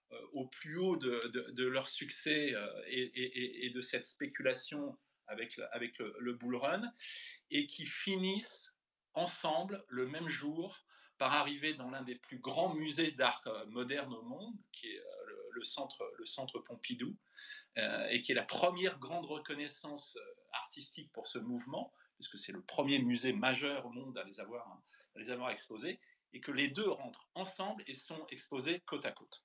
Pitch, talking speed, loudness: 155 Hz, 175 wpm, -40 LUFS